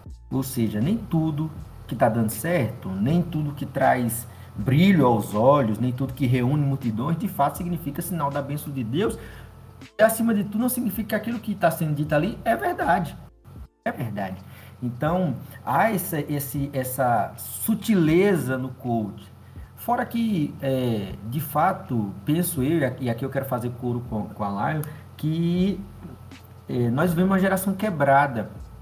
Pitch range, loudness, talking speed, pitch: 115-170 Hz, -24 LUFS, 160 wpm, 140 Hz